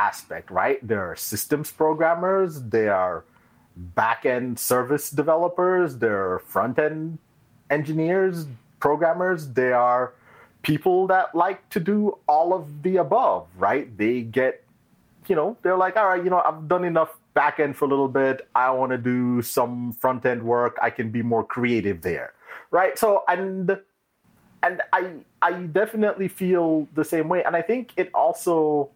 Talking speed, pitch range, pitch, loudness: 155 wpm, 125-180 Hz, 155 Hz, -23 LUFS